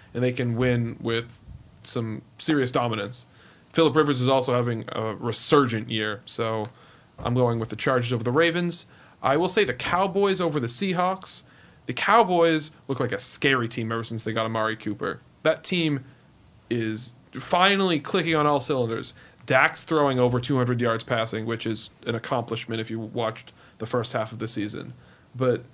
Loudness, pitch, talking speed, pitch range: -25 LUFS, 120 Hz, 175 wpm, 115-150 Hz